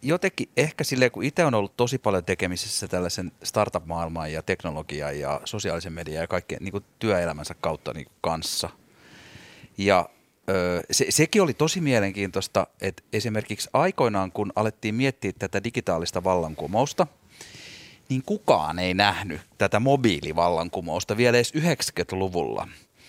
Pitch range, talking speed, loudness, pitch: 90-120 Hz, 125 wpm, -25 LUFS, 100 Hz